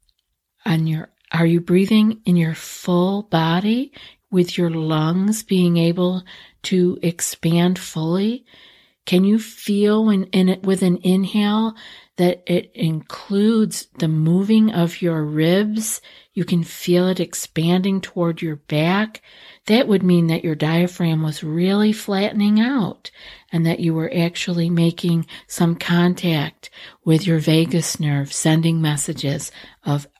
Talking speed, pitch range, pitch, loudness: 135 wpm, 165-195 Hz, 175 Hz, -19 LUFS